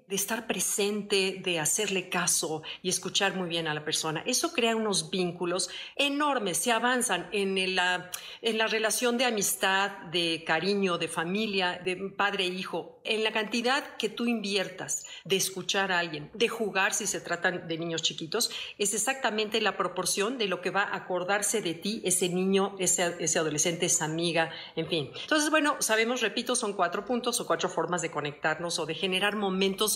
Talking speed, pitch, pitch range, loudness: 180 wpm, 195 Hz, 175-220 Hz, -28 LUFS